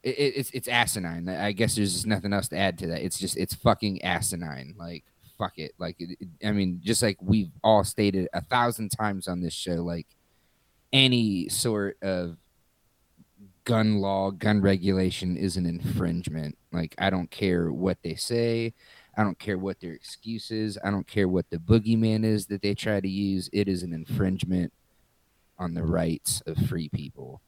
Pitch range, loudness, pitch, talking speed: 90-110 Hz, -27 LUFS, 95 Hz, 185 wpm